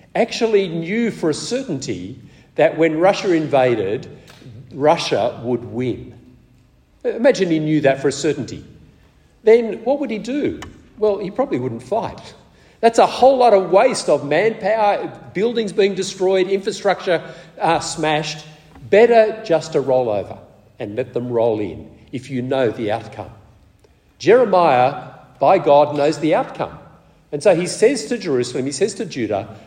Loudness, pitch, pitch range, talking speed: -18 LUFS, 160 Hz, 130-205 Hz, 150 wpm